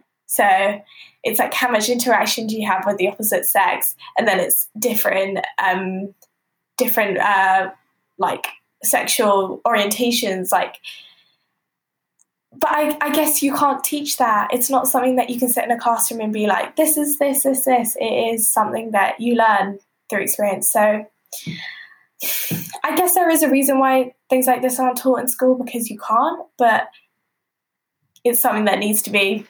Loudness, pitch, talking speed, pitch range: -18 LUFS, 240 Hz, 170 wpm, 205-260 Hz